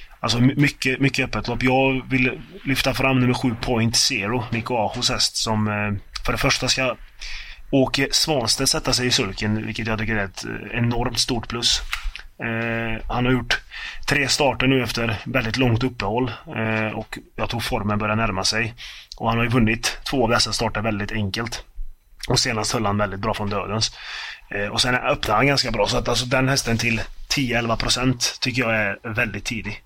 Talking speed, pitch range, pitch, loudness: 180 wpm, 110-130 Hz, 120 Hz, -21 LUFS